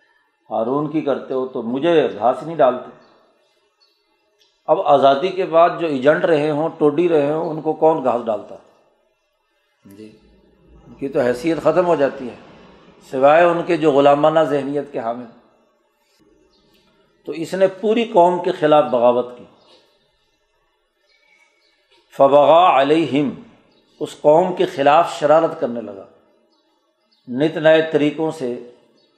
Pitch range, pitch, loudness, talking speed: 135-165 Hz, 150 Hz, -17 LUFS, 130 wpm